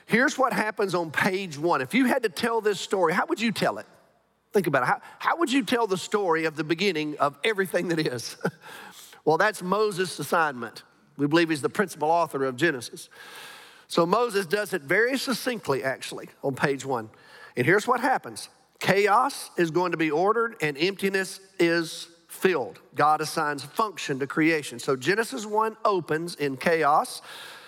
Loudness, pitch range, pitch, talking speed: -25 LUFS, 155-220 Hz, 180 Hz, 180 wpm